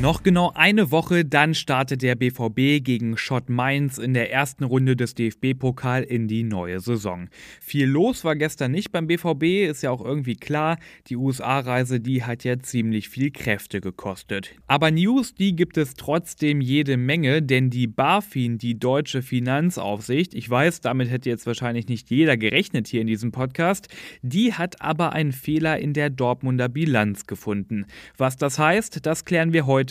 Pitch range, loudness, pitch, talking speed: 120-155 Hz, -22 LUFS, 130 Hz, 175 wpm